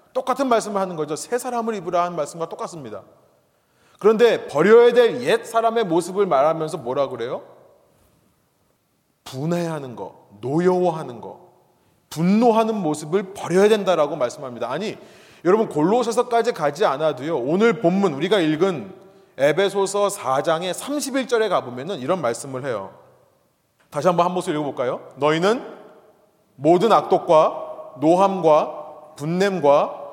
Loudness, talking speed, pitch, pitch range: -20 LUFS, 295 characters per minute, 190 Hz, 155-225 Hz